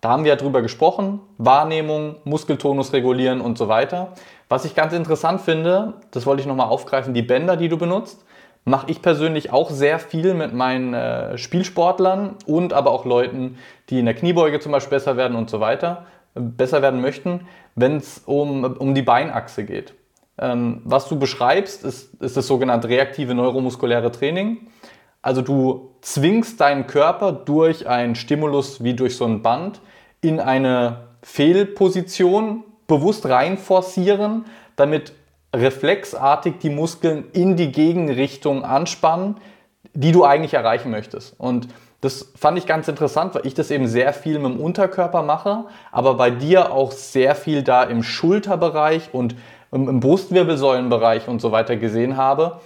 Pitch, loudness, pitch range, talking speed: 145 Hz, -19 LUFS, 130-175 Hz, 155 wpm